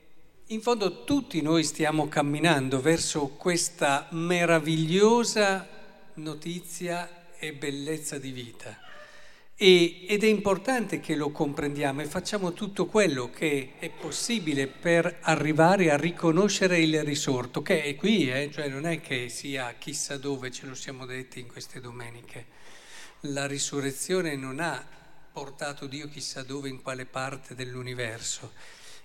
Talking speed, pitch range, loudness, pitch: 130 wpm, 140-175 Hz, -27 LUFS, 155 Hz